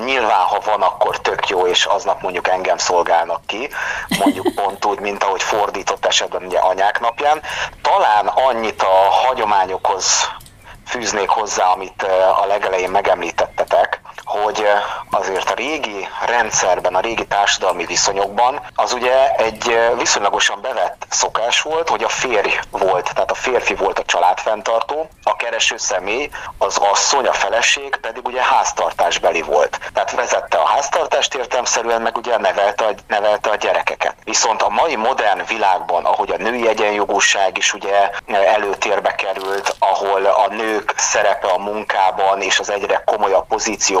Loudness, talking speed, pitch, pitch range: -17 LUFS, 145 wpm, 105 Hz, 95-115 Hz